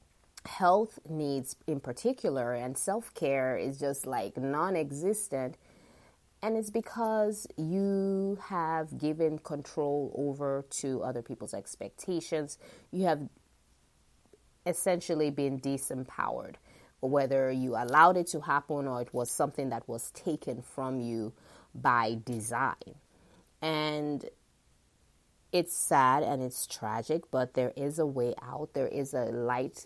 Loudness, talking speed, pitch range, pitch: -32 LUFS, 120 wpm, 125-160 Hz, 140 Hz